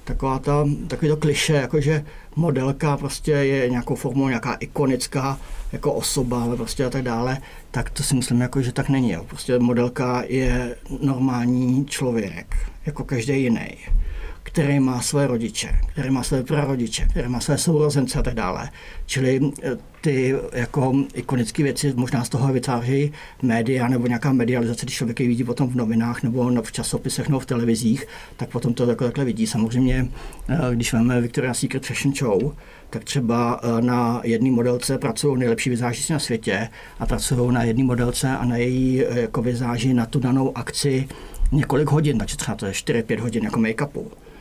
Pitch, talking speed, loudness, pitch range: 125 Hz, 160 wpm, -22 LUFS, 120-140 Hz